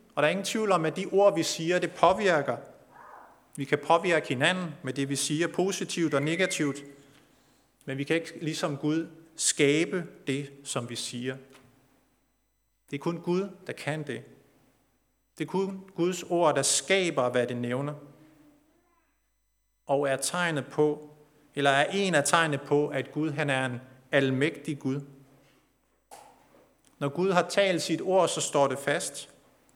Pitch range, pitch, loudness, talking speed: 135-170 Hz, 150 Hz, -28 LUFS, 160 wpm